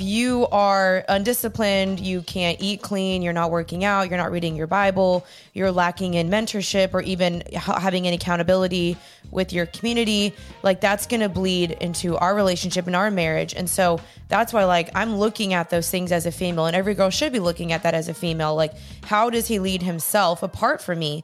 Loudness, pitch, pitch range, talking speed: -22 LUFS, 185 Hz, 175-200 Hz, 205 wpm